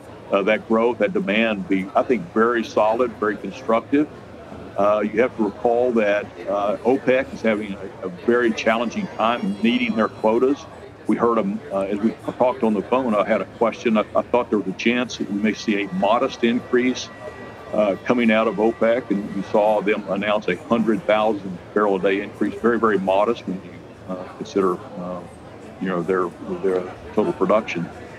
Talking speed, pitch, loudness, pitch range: 190 wpm, 110 Hz, -21 LUFS, 100-120 Hz